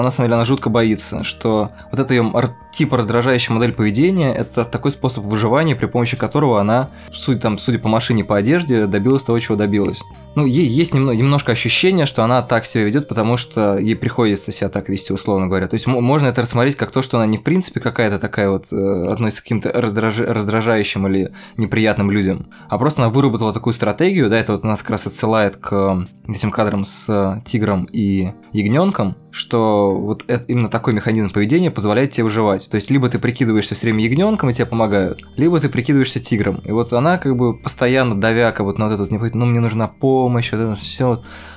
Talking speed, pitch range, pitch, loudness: 210 wpm, 105-125 Hz, 115 Hz, -17 LUFS